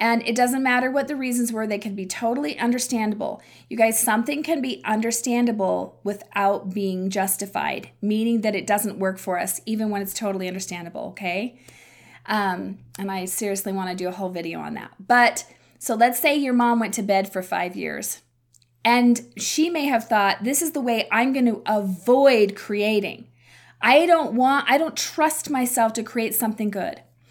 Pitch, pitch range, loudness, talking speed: 220 Hz, 195-245 Hz, -22 LUFS, 180 wpm